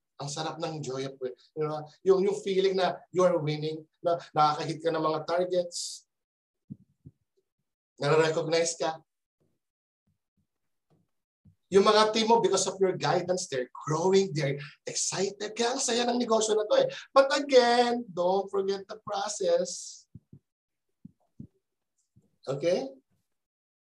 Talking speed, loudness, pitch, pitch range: 125 wpm, -27 LUFS, 180 Hz, 155-210 Hz